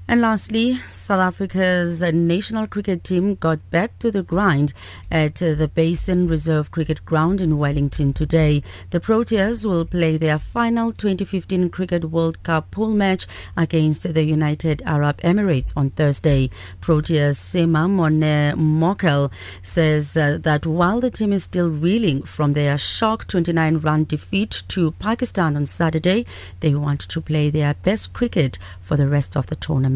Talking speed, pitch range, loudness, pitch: 145 wpm, 150-185 Hz, -20 LUFS, 165 Hz